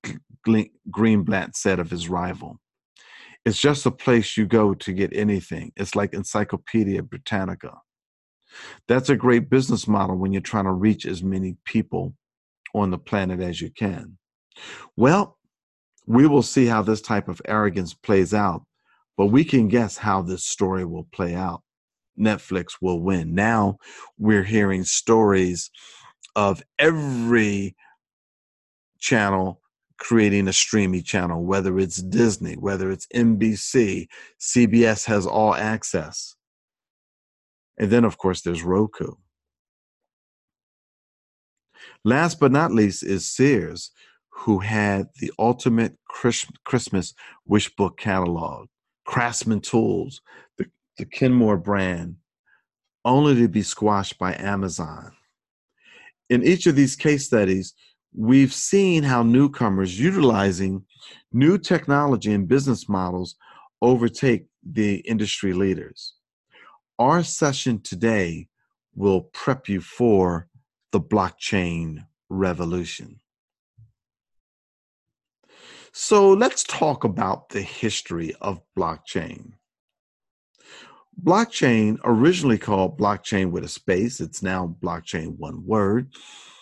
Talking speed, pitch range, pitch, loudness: 115 wpm, 95-120 Hz, 105 Hz, -21 LUFS